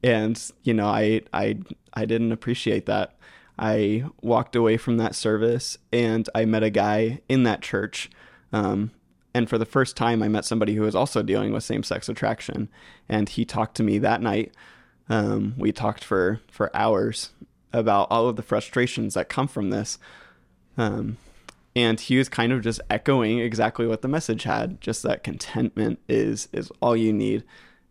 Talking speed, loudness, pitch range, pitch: 180 wpm, -24 LUFS, 105-120 Hz, 110 Hz